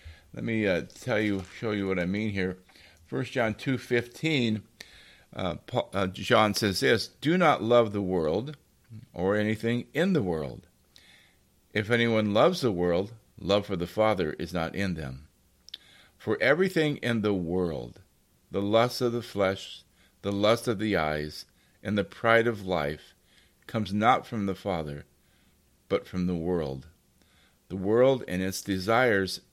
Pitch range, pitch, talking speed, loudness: 90-115 Hz, 100 Hz, 160 wpm, -27 LUFS